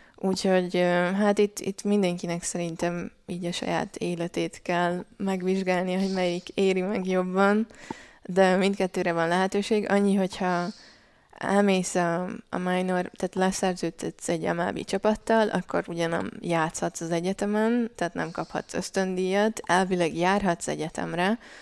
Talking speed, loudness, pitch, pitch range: 120 wpm, -26 LUFS, 185 Hz, 175-200 Hz